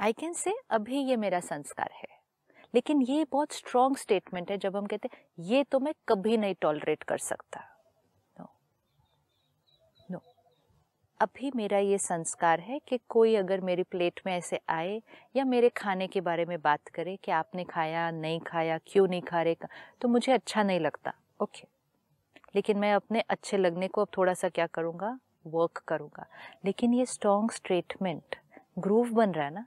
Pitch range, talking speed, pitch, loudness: 175-235 Hz, 175 wpm, 200 Hz, -30 LUFS